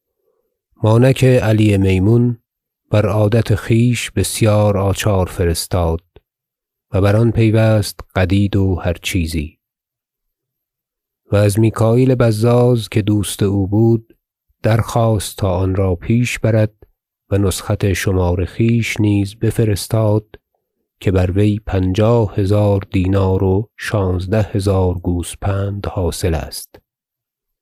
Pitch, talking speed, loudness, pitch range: 105 Hz, 105 wpm, -16 LUFS, 95-110 Hz